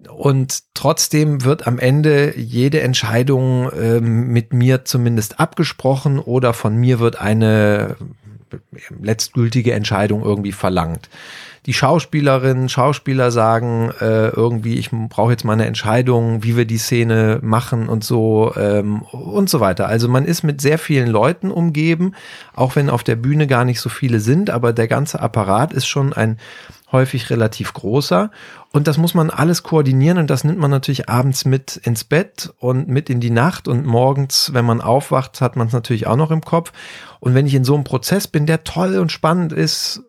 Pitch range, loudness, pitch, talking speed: 115-145 Hz, -16 LUFS, 130 Hz, 175 wpm